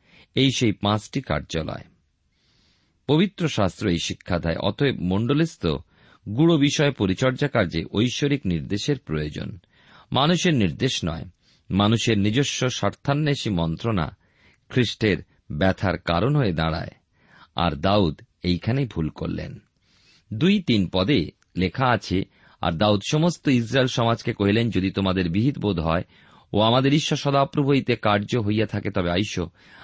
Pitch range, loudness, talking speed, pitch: 95-135 Hz, -23 LUFS, 120 wpm, 105 Hz